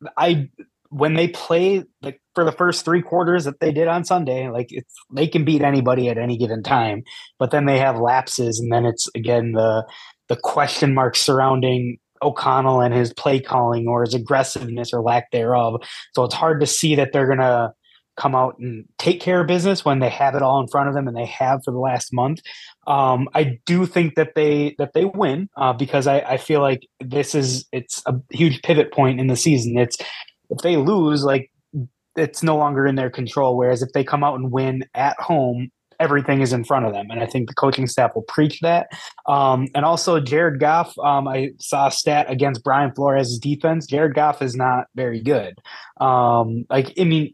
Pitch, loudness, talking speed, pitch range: 135 Hz, -19 LUFS, 210 wpm, 125-150 Hz